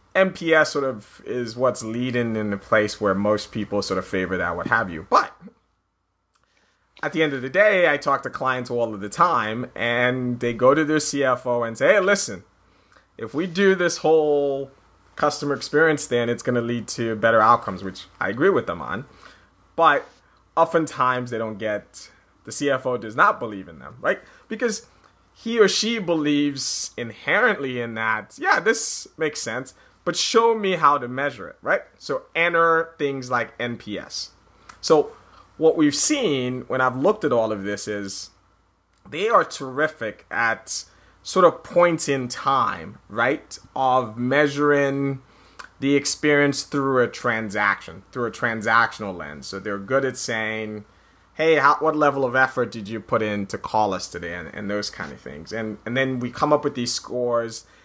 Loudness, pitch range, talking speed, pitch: -22 LUFS, 110-150 Hz, 175 wpm, 125 Hz